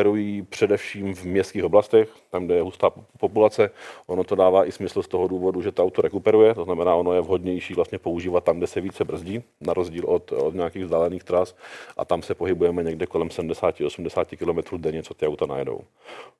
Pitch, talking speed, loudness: 110 Hz, 200 wpm, -23 LUFS